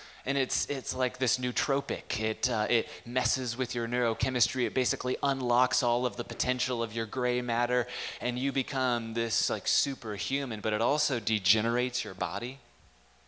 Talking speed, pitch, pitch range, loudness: 165 wpm, 125 Hz, 115-130 Hz, -29 LUFS